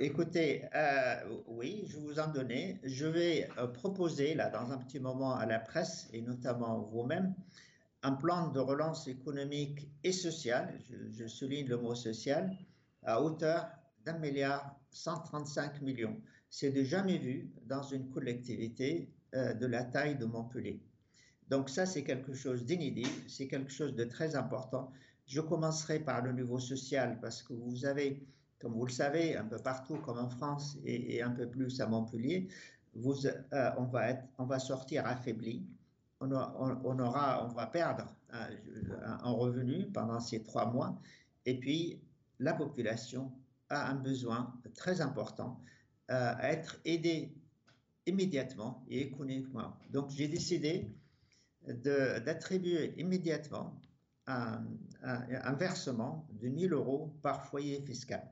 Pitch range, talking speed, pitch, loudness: 125-150 Hz, 150 wpm, 135 Hz, -38 LUFS